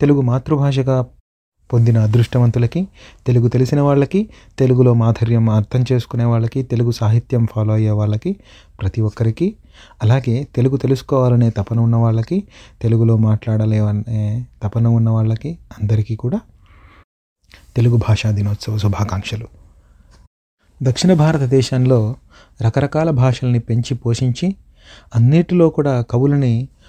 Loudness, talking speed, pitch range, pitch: -17 LUFS, 100 wpm, 110-130 Hz, 120 Hz